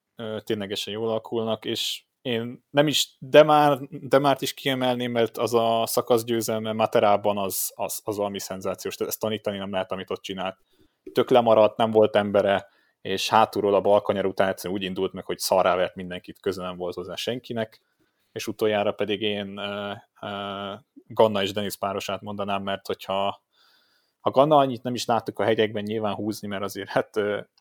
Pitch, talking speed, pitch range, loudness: 105 Hz, 165 wpm, 100-115 Hz, -24 LUFS